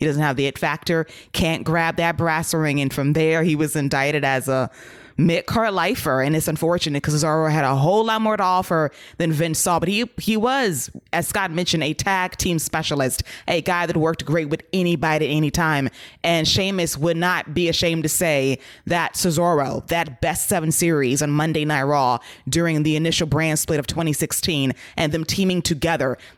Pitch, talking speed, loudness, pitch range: 160 Hz, 195 wpm, -20 LUFS, 150-170 Hz